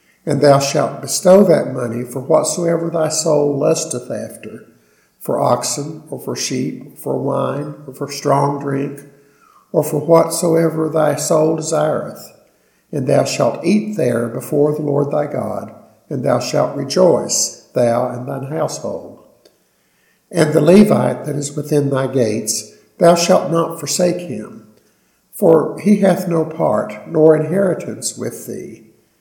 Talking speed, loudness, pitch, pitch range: 145 wpm, -16 LUFS, 150 Hz, 140-165 Hz